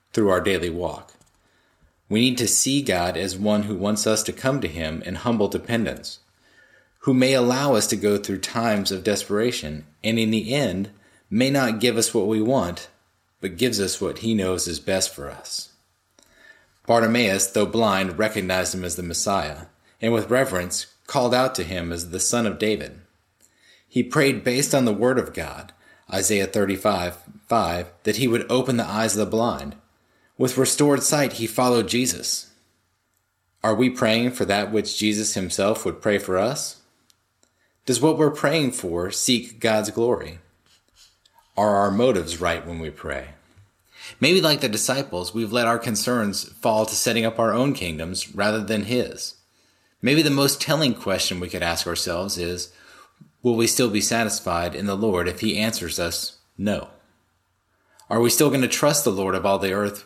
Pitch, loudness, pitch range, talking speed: 105 Hz, -22 LUFS, 90-120 Hz, 180 wpm